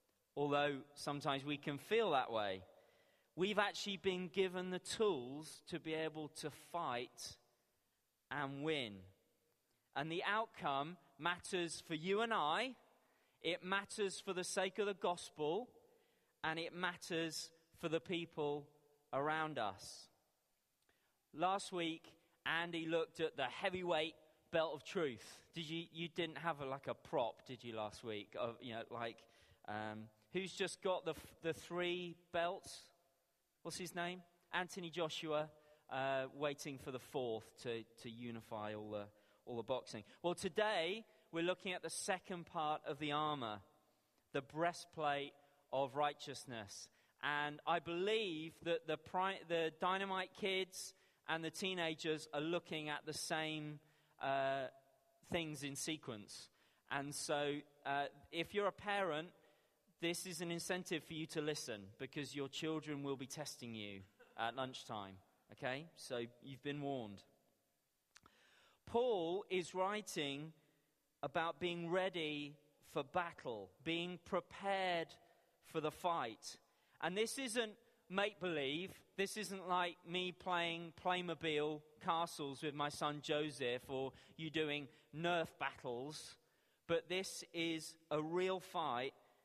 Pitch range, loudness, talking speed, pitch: 145-175 Hz, -43 LUFS, 140 wpm, 160 Hz